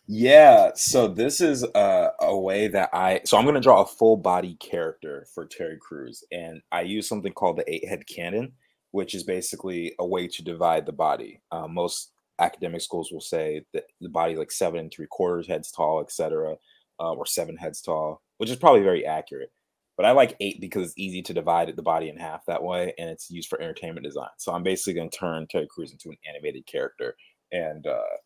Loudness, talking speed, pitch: -23 LUFS, 220 wpm, 340 Hz